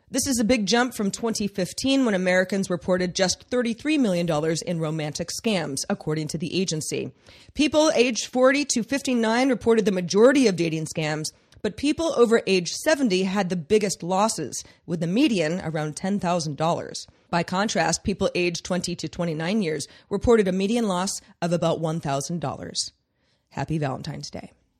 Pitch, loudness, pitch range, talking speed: 185 Hz, -24 LUFS, 165-230 Hz, 150 wpm